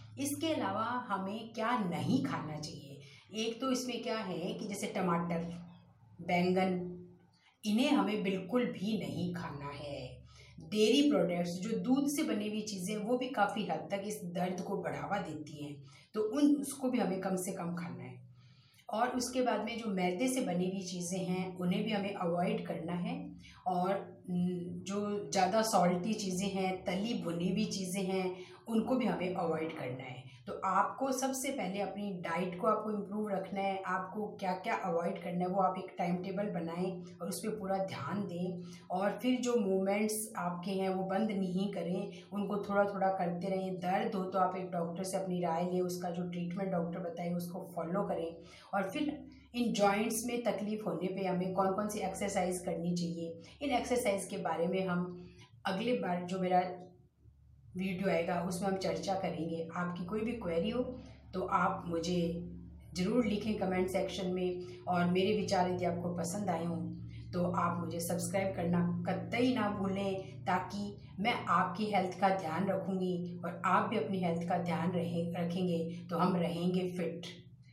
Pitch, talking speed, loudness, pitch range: 185 Hz, 175 wpm, -35 LUFS, 175-205 Hz